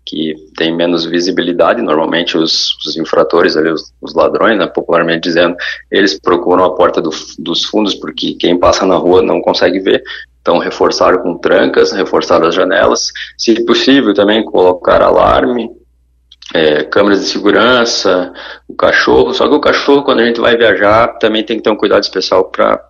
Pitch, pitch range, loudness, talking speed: 95 Hz, 80-115 Hz, -11 LUFS, 170 wpm